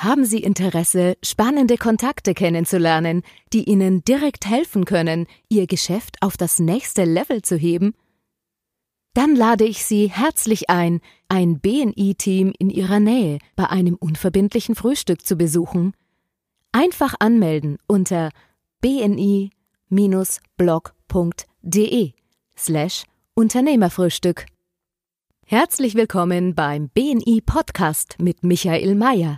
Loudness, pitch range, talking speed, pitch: -19 LUFS, 175-225 Hz, 100 wpm, 190 Hz